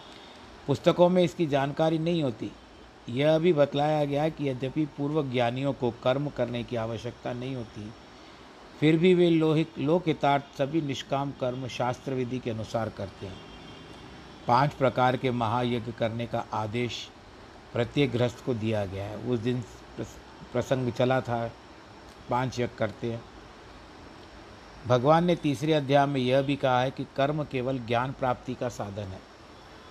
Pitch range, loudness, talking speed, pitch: 120-145 Hz, -27 LUFS, 150 wpm, 125 Hz